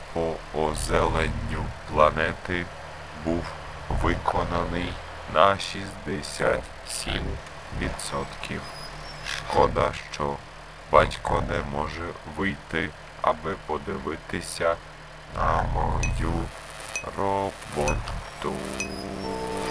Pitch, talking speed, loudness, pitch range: 80 Hz, 55 wpm, -27 LUFS, 75-85 Hz